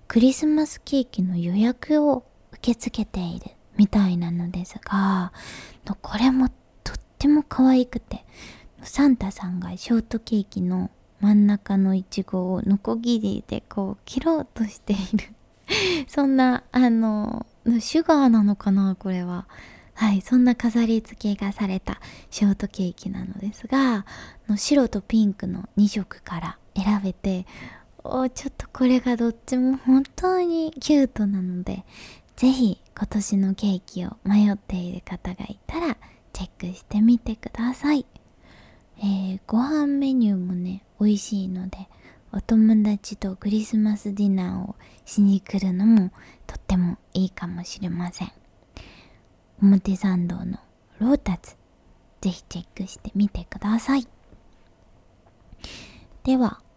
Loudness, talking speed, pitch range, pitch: -23 LUFS, 270 characters per minute, 190-240 Hz, 205 Hz